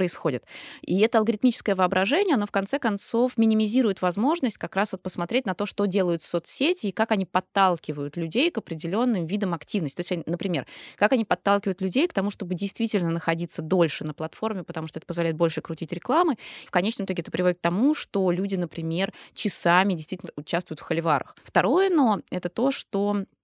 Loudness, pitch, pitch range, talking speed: -25 LUFS, 190 Hz, 170-220 Hz, 180 wpm